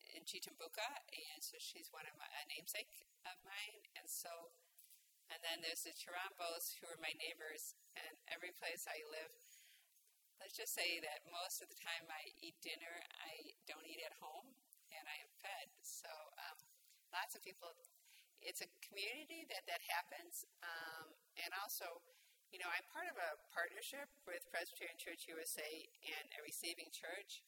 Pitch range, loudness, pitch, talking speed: 165-210 Hz, -50 LUFS, 170 Hz, 170 wpm